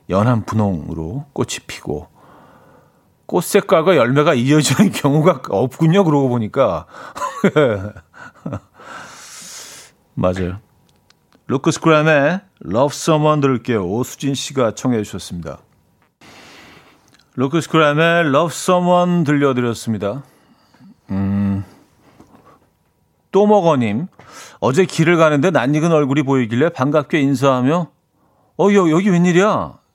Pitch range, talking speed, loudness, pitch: 115-165 Hz, 235 characters per minute, -16 LUFS, 140 Hz